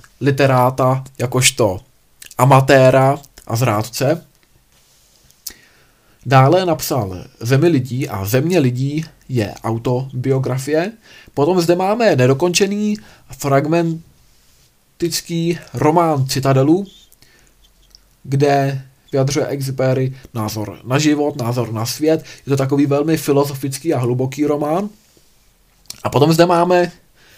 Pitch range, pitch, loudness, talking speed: 125-160 Hz, 135 Hz, -16 LUFS, 90 wpm